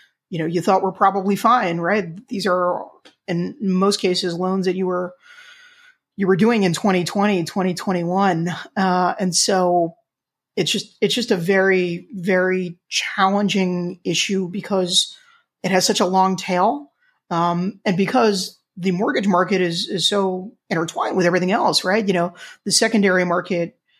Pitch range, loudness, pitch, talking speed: 180-205 Hz, -19 LUFS, 190 Hz, 155 wpm